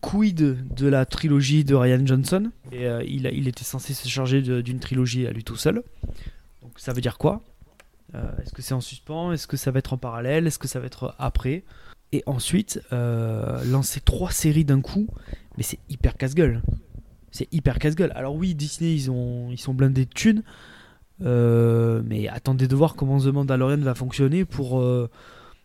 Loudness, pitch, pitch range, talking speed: -24 LUFS, 130 Hz, 125-145 Hz, 195 wpm